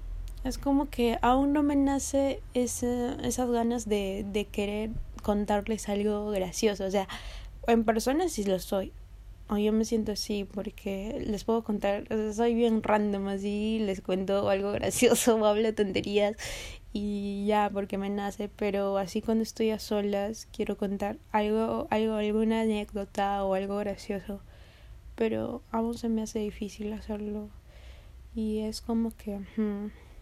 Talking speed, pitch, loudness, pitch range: 155 wpm, 210 Hz, -29 LUFS, 200-225 Hz